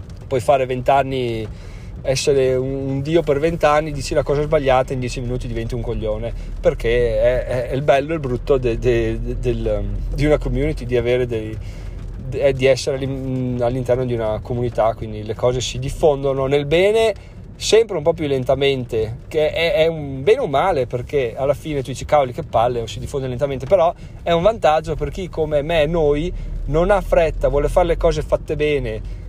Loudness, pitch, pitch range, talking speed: -19 LUFS, 135 Hz, 120-150 Hz, 180 wpm